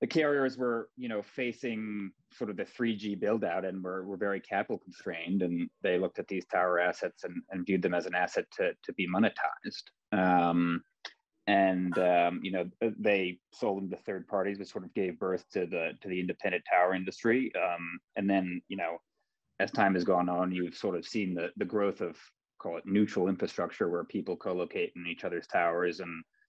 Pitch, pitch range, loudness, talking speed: 95 Hz, 90-105 Hz, -32 LUFS, 200 wpm